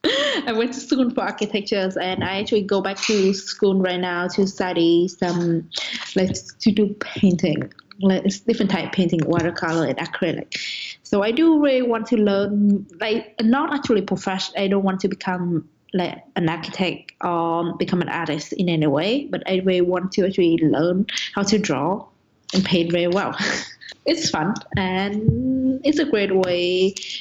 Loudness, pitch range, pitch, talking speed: -21 LUFS, 175-215 Hz, 190 Hz, 170 wpm